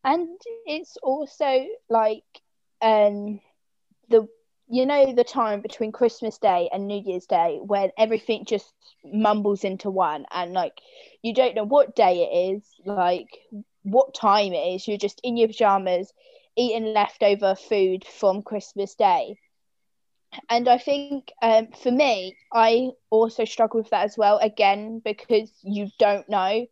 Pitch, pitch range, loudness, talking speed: 220 Hz, 200-245 Hz, -23 LUFS, 150 wpm